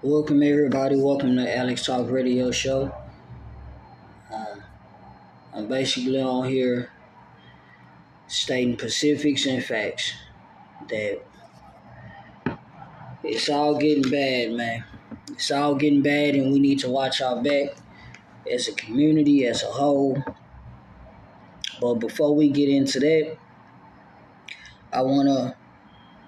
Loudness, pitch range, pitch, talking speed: -23 LUFS, 125-145 Hz, 135 Hz, 110 wpm